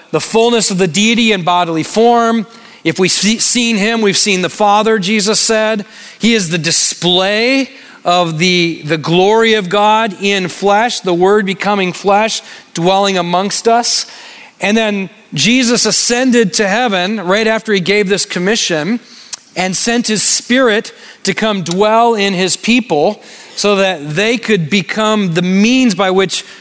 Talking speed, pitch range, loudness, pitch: 155 wpm, 185-225 Hz, -11 LUFS, 205 Hz